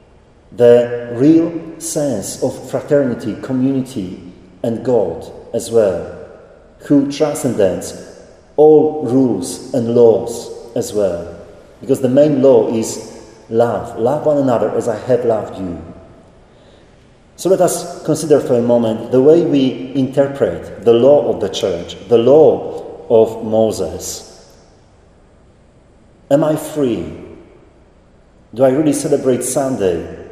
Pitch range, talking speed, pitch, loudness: 130-175 Hz, 120 wpm, 145 Hz, -15 LUFS